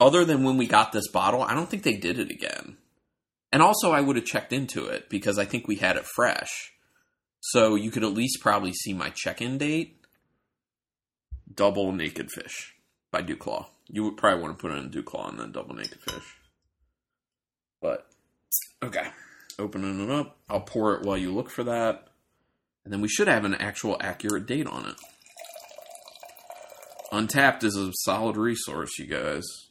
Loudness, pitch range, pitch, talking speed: -26 LUFS, 100-145 Hz, 110 Hz, 185 wpm